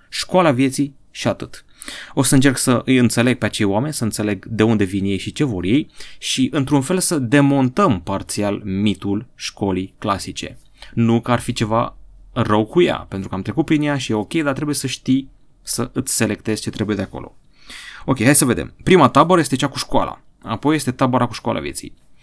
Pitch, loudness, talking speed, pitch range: 120 Hz, -18 LUFS, 205 wpm, 105-140 Hz